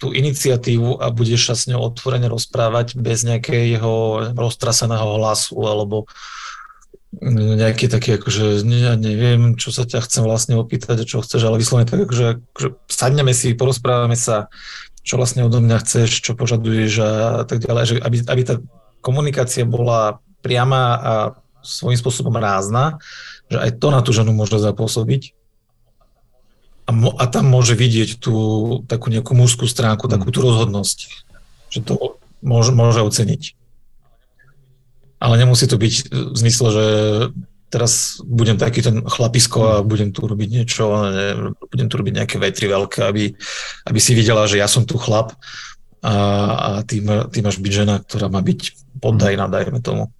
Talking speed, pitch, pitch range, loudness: 150 wpm, 115 Hz, 110-125 Hz, -17 LUFS